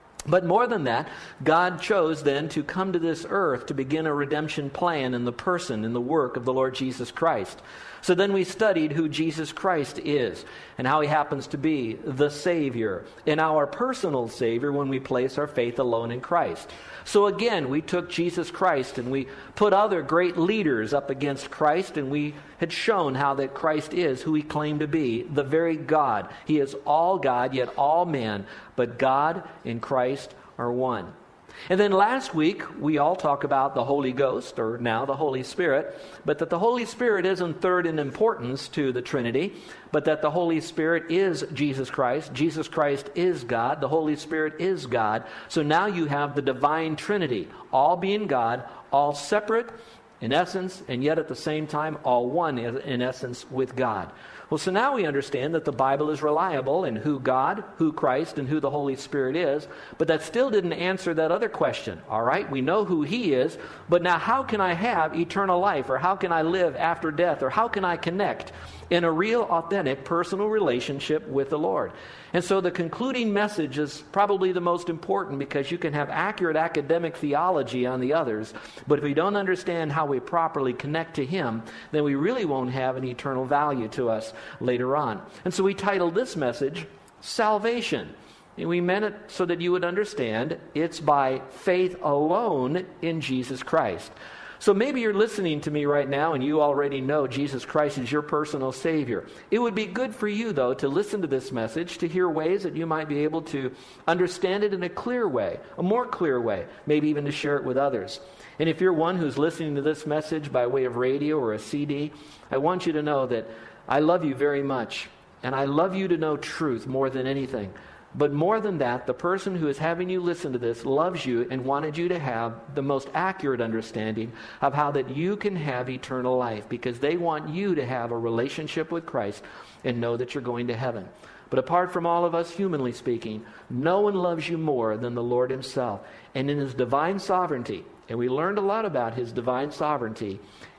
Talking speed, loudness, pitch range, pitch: 205 wpm, -26 LUFS, 130-175 Hz, 150 Hz